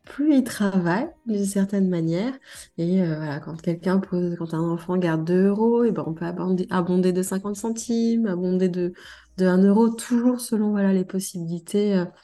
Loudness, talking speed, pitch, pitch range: -23 LUFS, 185 wpm, 185 Hz, 175-220 Hz